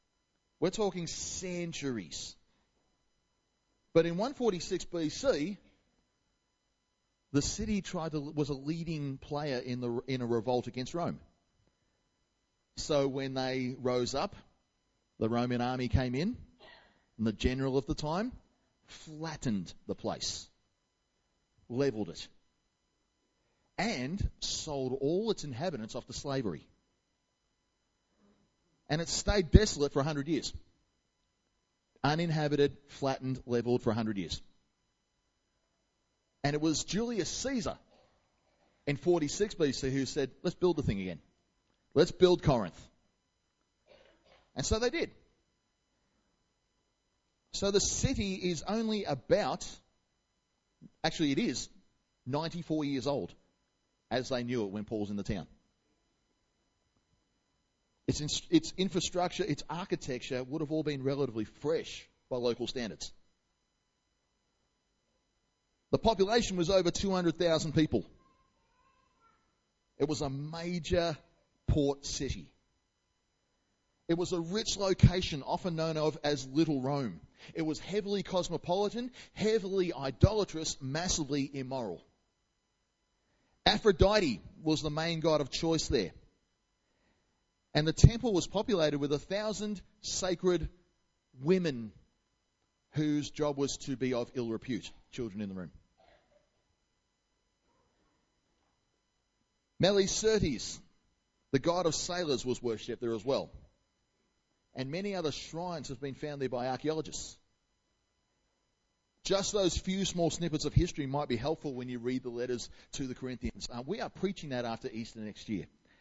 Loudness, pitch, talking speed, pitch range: -33 LUFS, 145 Hz, 120 wpm, 125-175 Hz